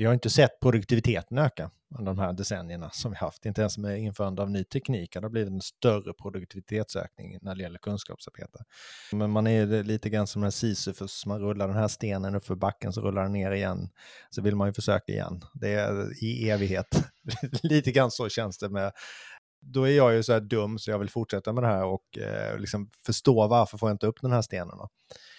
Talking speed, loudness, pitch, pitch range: 215 wpm, -28 LUFS, 105 Hz, 100-115 Hz